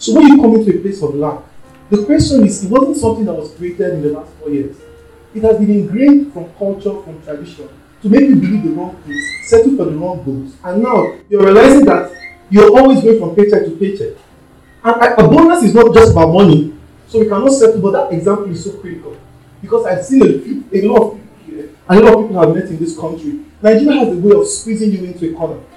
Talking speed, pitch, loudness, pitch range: 240 wpm, 205 Hz, -11 LUFS, 165-230 Hz